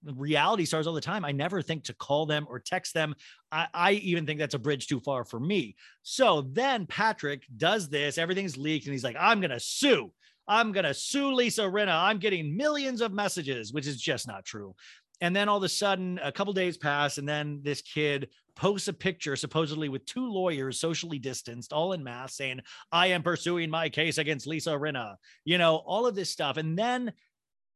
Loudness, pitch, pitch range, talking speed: -29 LUFS, 160 Hz, 145-190 Hz, 210 wpm